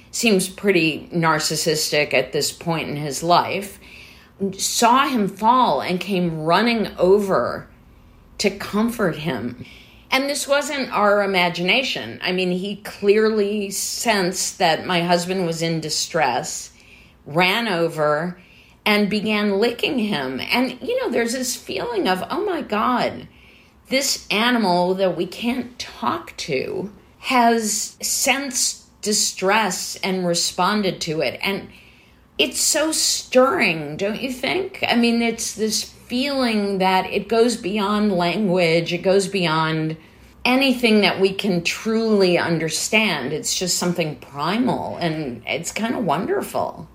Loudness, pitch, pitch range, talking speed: -20 LUFS, 195 Hz, 175-230 Hz, 130 wpm